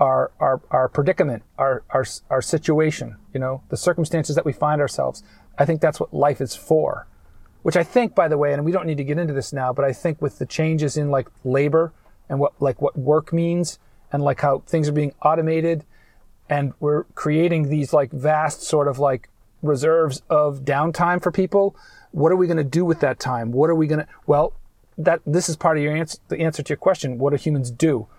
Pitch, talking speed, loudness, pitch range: 150 Hz, 225 wpm, -21 LUFS, 140-165 Hz